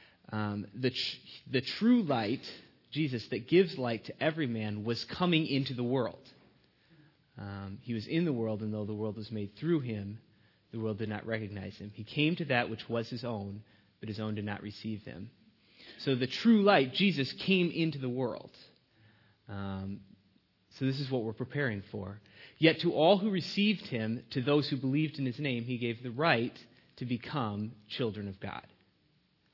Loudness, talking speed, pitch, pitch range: -32 LUFS, 185 wpm, 120 Hz, 105-145 Hz